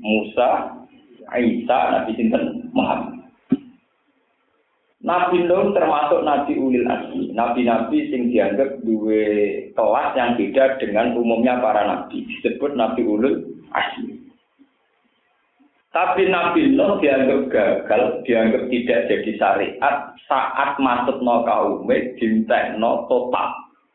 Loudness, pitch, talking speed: -19 LUFS, 150 Hz, 105 wpm